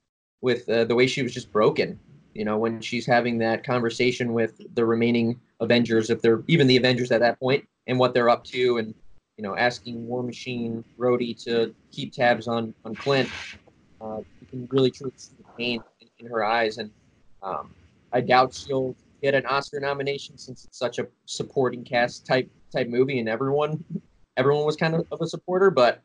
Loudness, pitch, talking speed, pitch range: -24 LUFS, 125 Hz, 195 wpm, 115-130 Hz